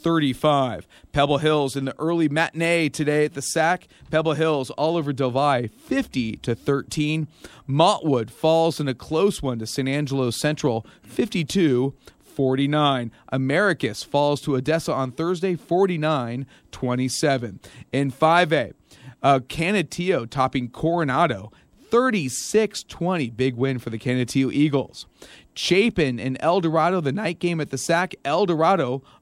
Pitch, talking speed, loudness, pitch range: 145 Hz, 135 wpm, -22 LUFS, 130-165 Hz